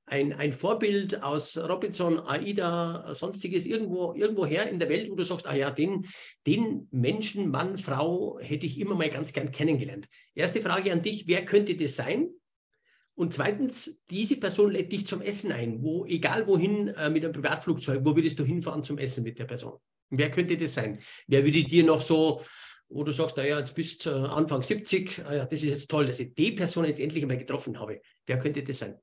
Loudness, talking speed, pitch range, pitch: -28 LUFS, 205 wpm, 145-190 Hz, 160 Hz